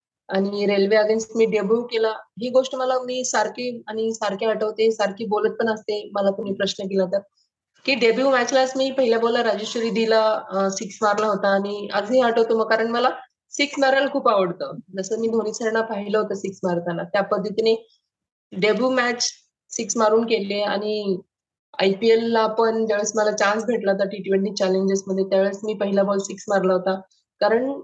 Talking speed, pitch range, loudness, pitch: 170 wpm, 200-230 Hz, -22 LUFS, 215 Hz